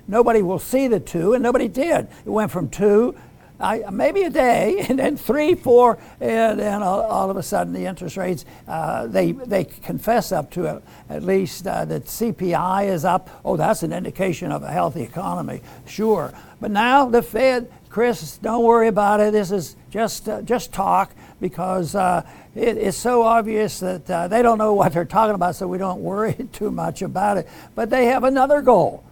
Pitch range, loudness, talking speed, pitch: 185-235 Hz, -20 LUFS, 195 wpm, 210 Hz